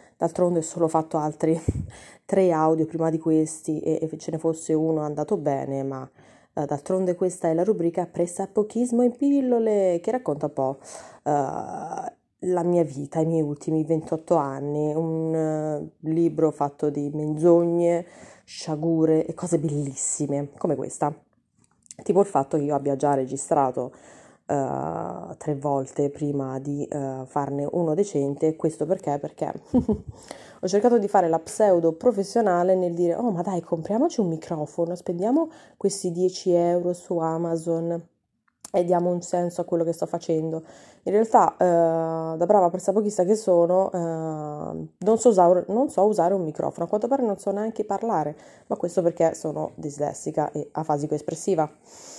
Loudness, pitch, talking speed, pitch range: -24 LUFS, 165 Hz, 160 wpm, 150-185 Hz